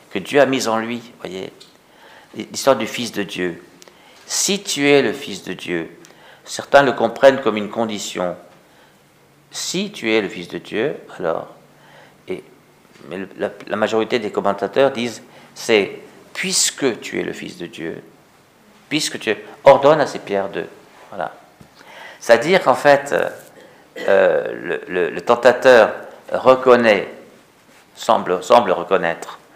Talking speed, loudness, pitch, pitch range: 145 wpm, -17 LUFS, 120 Hz, 100-140 Hz